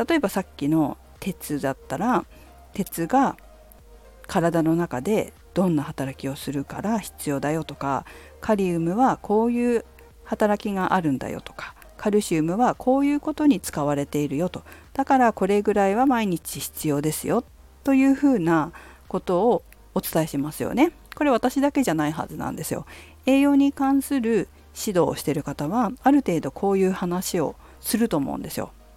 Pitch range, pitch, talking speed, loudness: 150-250 Hz, 190 Hz, 350 characters per minute, -24 LUFS